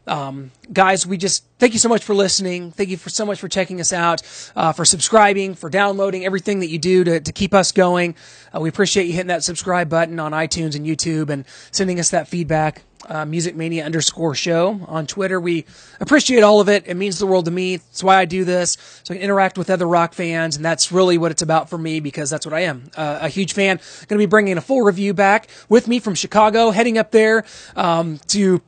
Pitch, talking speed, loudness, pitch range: 180 Hz, 240 wpm, -17 LUFS, 165-195 Hz